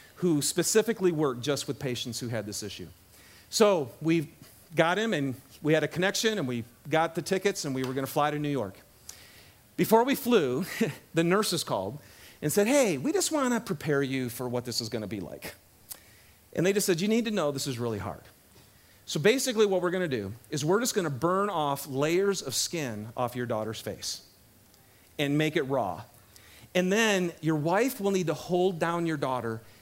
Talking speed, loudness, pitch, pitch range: 200 wpm, -28 LUFS, 155 Hz, 125-190 Hz